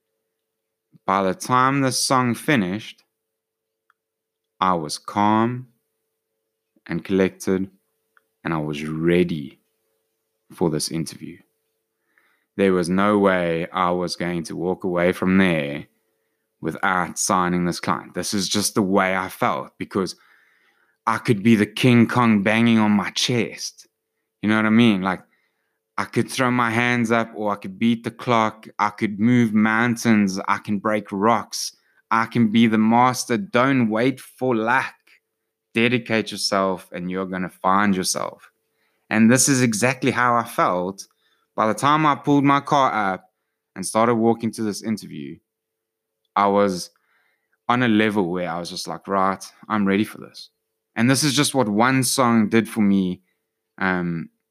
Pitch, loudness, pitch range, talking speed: 110 Hz, -20 LUFS, 95-115 Hz, 155 wpm